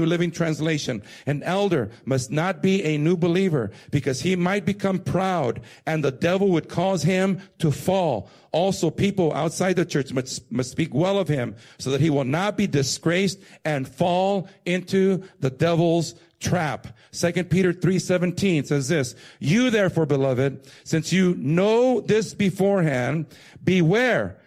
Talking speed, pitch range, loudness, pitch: 150 wpm, 145-185 Hz, -23 LUFS, 170 Hz